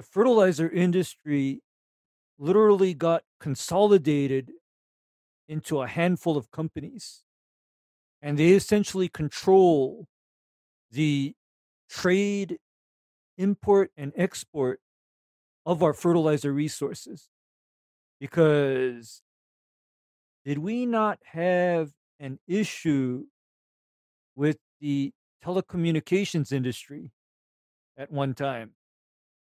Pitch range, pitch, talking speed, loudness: 140-180 Hz, 155 Hz, 75 wpm, -25 LUFS